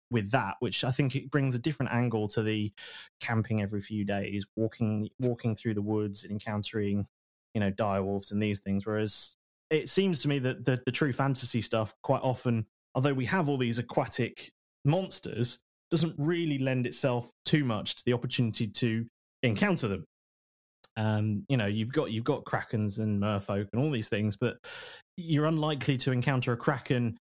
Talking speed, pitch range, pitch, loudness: 180 wpm, 105-135 Hz, 120 Hz, -31 LUFS